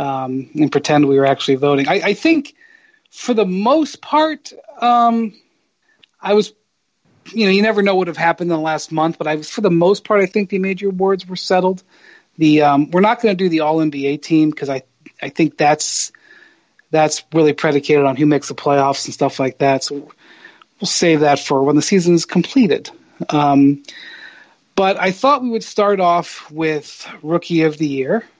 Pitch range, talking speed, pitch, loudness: 145-205 Hz, 200 wpm, 165 Hz, -16 LUFS